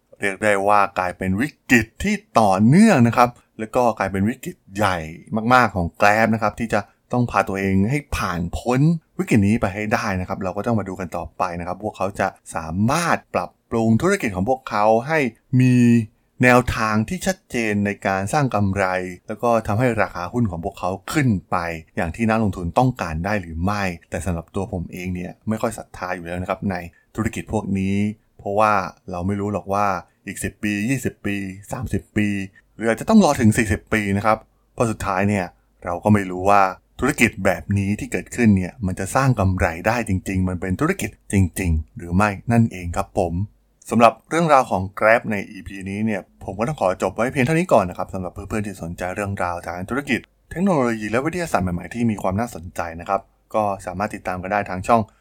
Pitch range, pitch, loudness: 95-115 Hz, 100 Hz, -21 LUFS